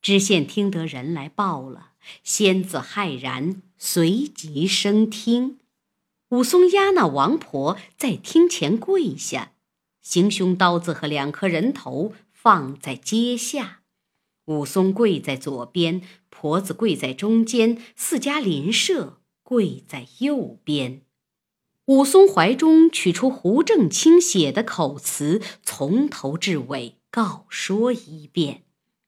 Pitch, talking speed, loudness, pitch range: 195 Hz, 165 characters per minute, -20 LUFS, 160-235 Hz